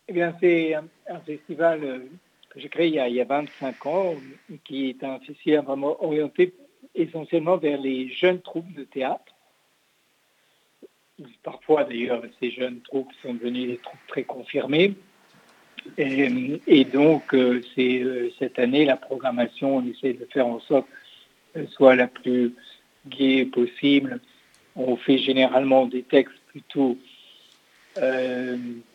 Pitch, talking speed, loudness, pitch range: 135 Hz, 135 wpm, -23 LUFS, 125-165 Hz